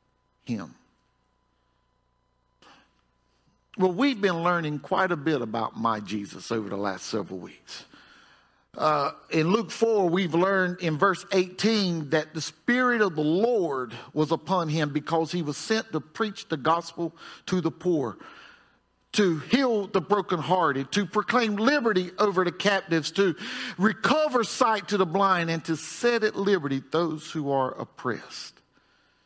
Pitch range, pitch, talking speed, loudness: 150-205 Hz, 175 Hz, 145 wpm, -26 LUFS